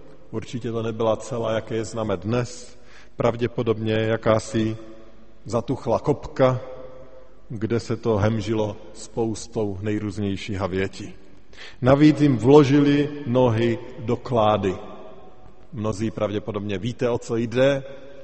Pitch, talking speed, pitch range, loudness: 115 Hz, 100 wpm, 110-125 Hz, -23 LUFS